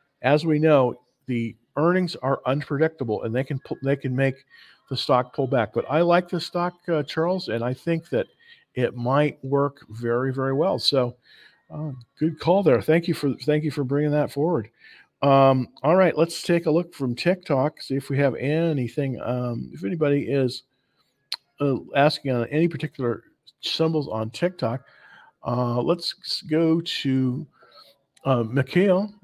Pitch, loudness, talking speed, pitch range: 140 Hz, -24 LUFS, 170 wpm, 125-160 Hz